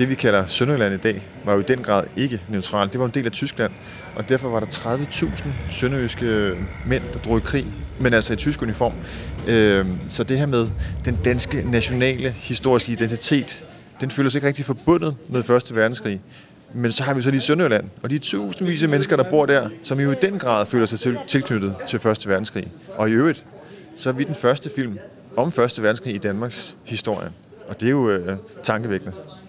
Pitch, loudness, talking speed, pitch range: 120 Hz, -21 LUFS, 205 wpm, 105-135 Hz